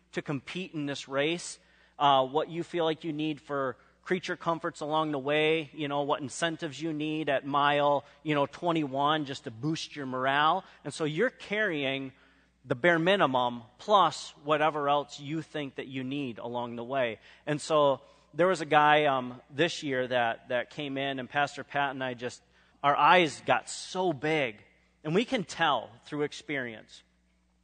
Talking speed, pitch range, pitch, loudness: 180 wpm, 135-160 Hz, 145 Hz, -29 LUFS